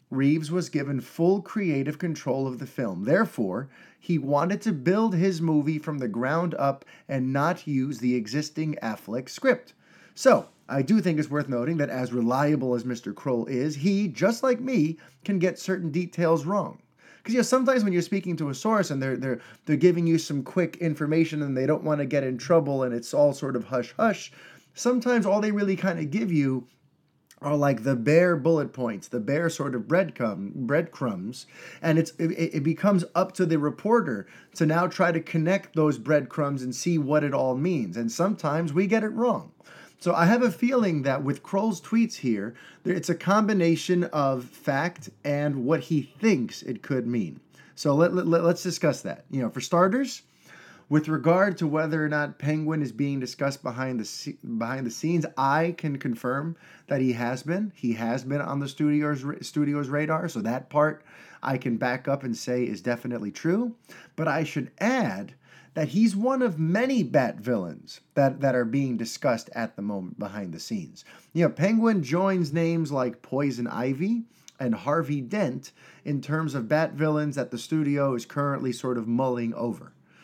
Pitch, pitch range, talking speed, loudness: 150 Hz, 135-175 Hz, 190 wpm, -26 LUFS